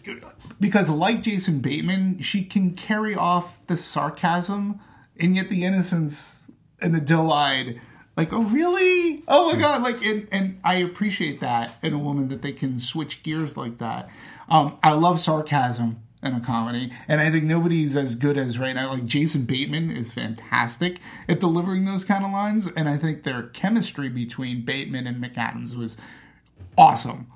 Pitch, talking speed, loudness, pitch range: 155 Hz, 170 wpm, -23 LUFS, 130-190 Hz